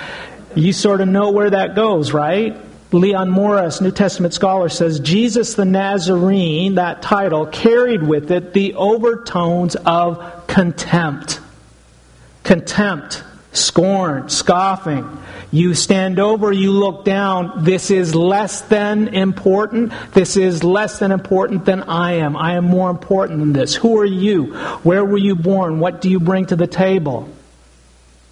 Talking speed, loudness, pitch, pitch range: 145 wpm, -15 LUFS, 185 Hz, 170-200 Hz